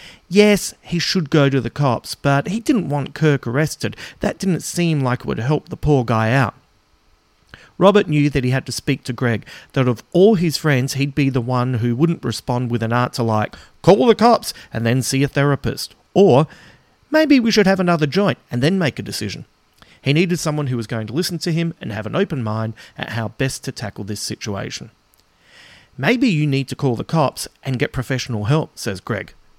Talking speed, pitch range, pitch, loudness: 210 wpm, 120-165 Hz, 140 Hz, -19 LUFS